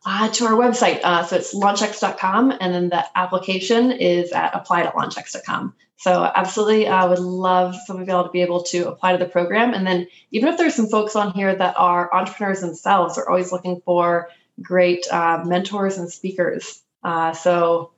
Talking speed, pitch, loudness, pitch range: 190 wpm, 185 Hz, -19 LUFS, 175-205 Hz